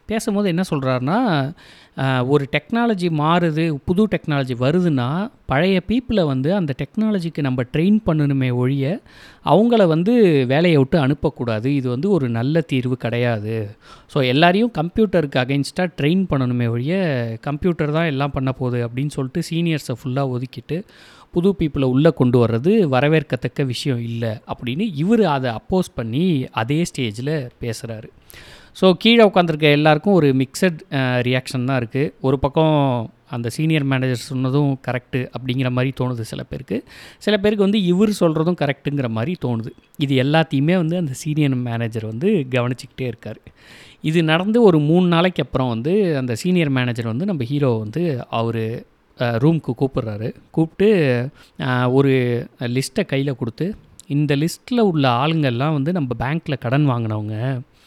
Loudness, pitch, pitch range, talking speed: -19 LUFS, 140 Hz, 125-170 Hz, 135 wpm